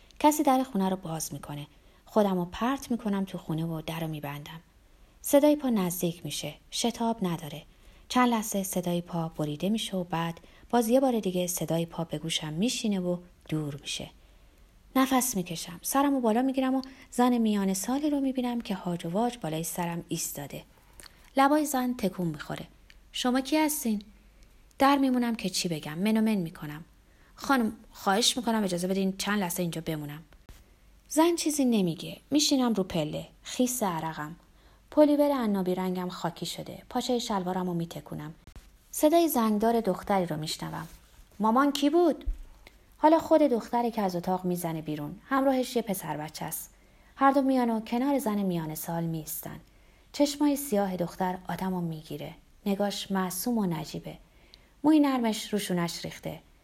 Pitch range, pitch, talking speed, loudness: 170-250 Hz, 195 Hz, 155 wpm, -28 LUFS